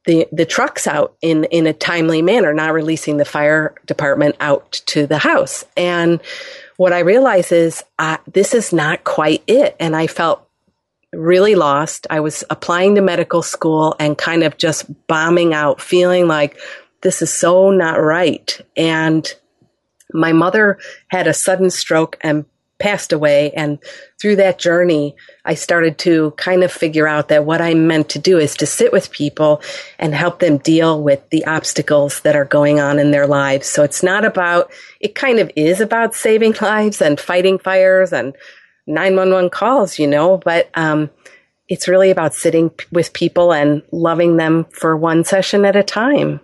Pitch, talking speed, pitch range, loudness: 165 Hz, 175 wpm, 155-185 Hz, -14 LUFS